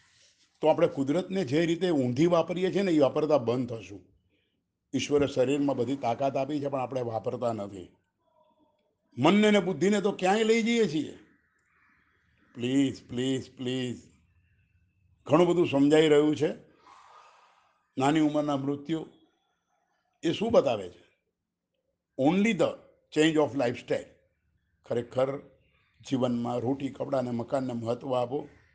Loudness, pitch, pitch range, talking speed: -27 LUFS, 140 Hz, 120-165 Hz, 120 wpm